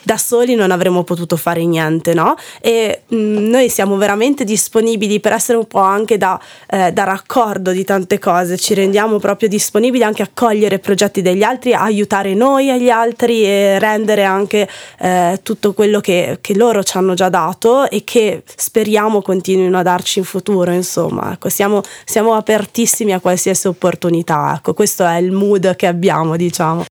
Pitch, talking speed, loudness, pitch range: 200 Hz, 170 wpm, -14 LUFS, 185-220 Hz